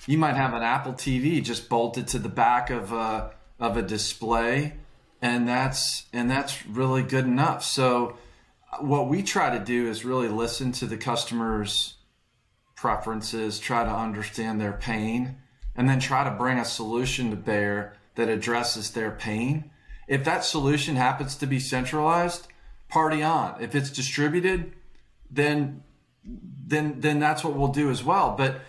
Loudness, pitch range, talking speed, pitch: -26 LUFS, 115-145 Hz, 160 wpm, 130 Hz